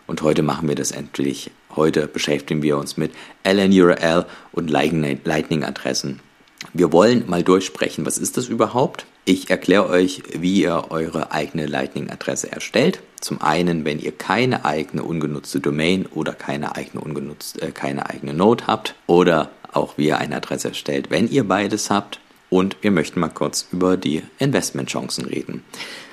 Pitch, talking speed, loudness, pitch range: 80 Hz, 150 wpm, -20 LUFS, 75-90 Hz